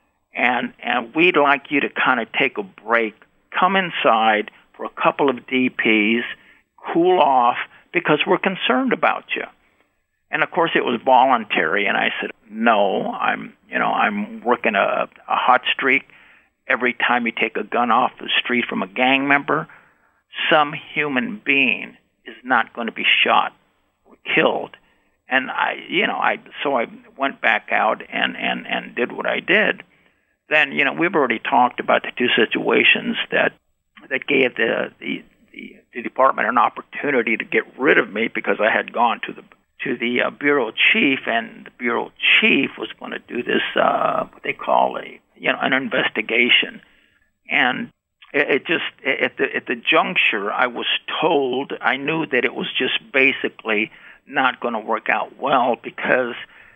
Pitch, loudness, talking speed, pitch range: 145 Hz, -19 LUFS, 175 wpm, 125-195 Hz